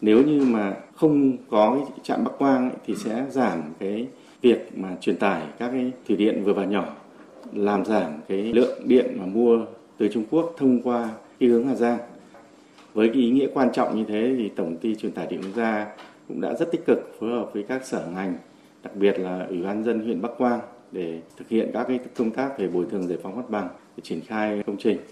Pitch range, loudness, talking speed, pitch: 105-125 Hz, -24 LUFS, 225 wpm, 115 Hz